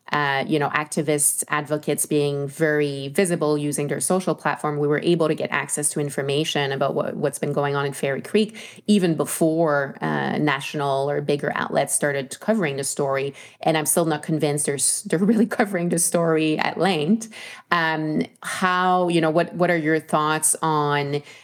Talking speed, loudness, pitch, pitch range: 180 wpm, -22 LUFS, 150 Hz, 145-170 Hz